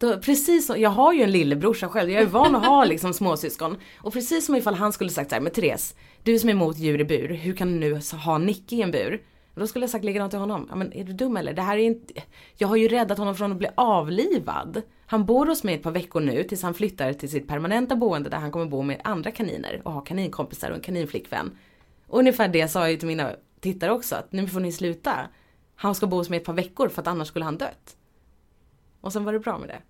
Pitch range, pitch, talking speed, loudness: 165-225 Hz, 195 Hz, 265 wpm, -24 LUFS